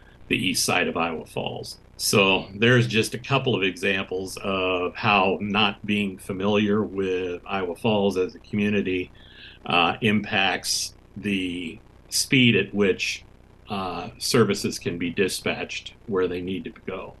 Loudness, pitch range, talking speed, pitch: -23 LUFS, 95-105 Hz, 140 wpm, 100 Hz